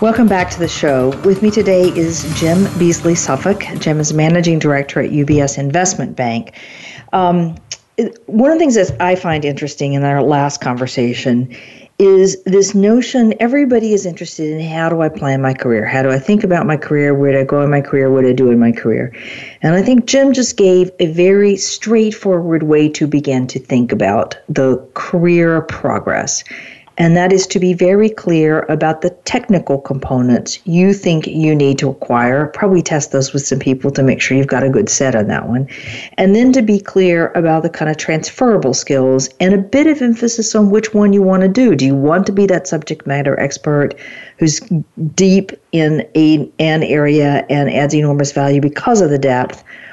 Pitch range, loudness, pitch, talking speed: 140-190 Hz, -13 LUFS, 160 Hz, 200 wpm